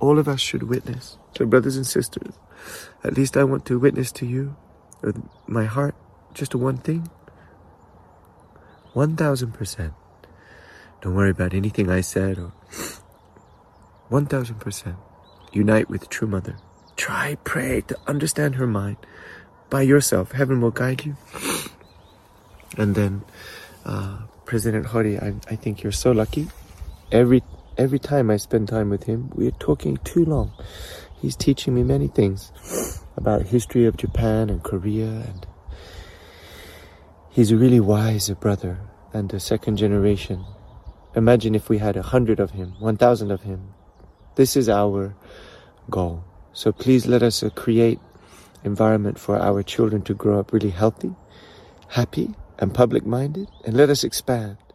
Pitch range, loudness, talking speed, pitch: 95-125 Hz, -22 LUFS, 145 wpm, 105 Hz